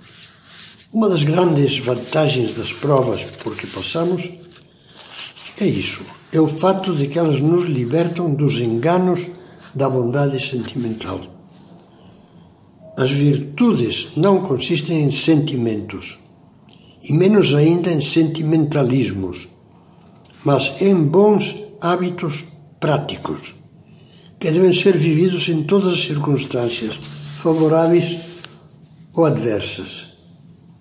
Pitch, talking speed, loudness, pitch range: 160 Hz, 100 wpm, -17 LUFS, 135-175 Hz